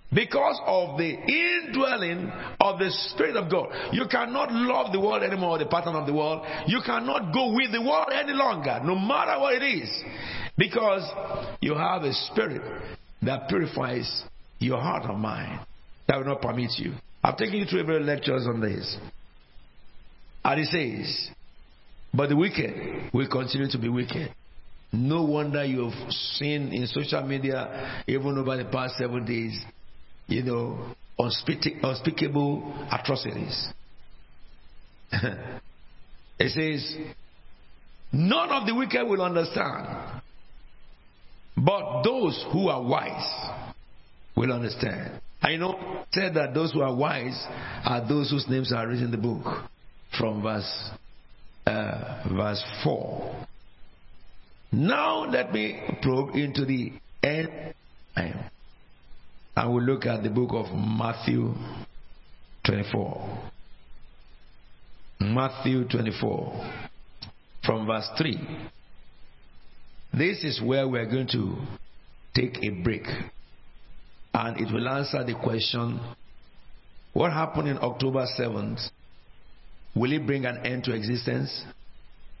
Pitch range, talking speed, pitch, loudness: 115-155 Hz, 125 wpm, 130 Hz, -27 LUFS